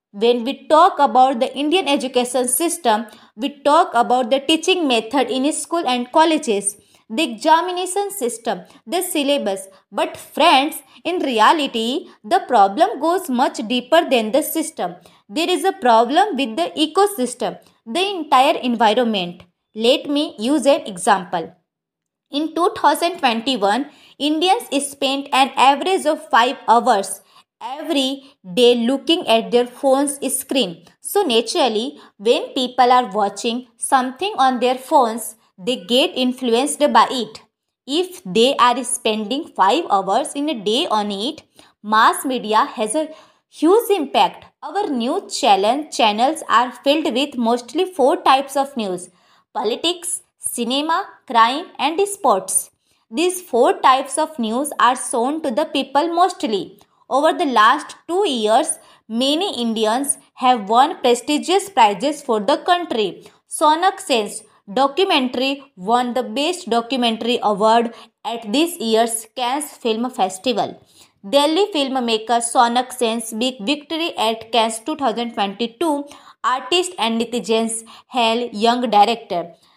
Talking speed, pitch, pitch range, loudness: 125 wpm, 265 Hz, 235-310 Hz, -18 LUFS